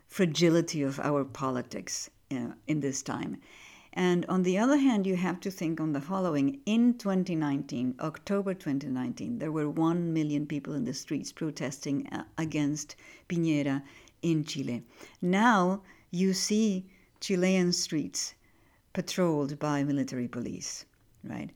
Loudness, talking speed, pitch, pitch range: -30 LUFS, 130 wpm, 165 Hz, 145-190 Hz